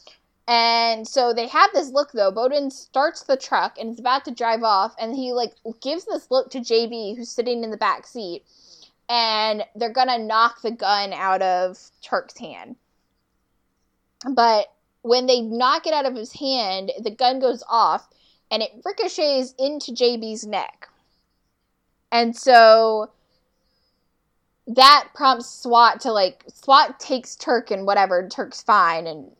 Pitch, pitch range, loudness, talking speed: 240 Hz, 225-265 Hz, -20 LUFS, 155 wpm